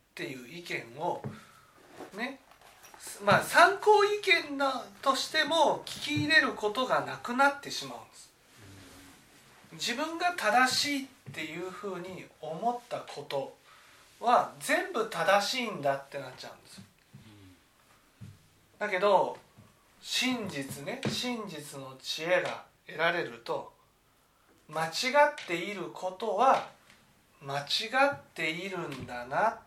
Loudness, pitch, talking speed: -29 LUFS, 200 Hz, 220 characters per minute